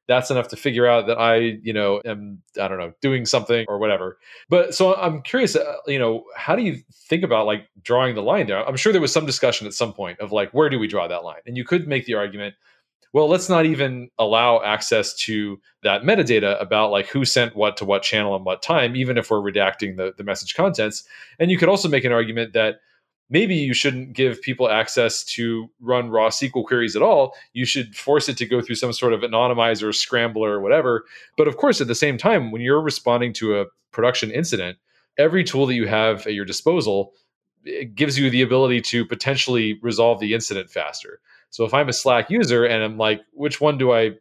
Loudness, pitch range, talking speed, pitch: -20 LUFS, 110-140 Hz, 225 wpm, 120 Hz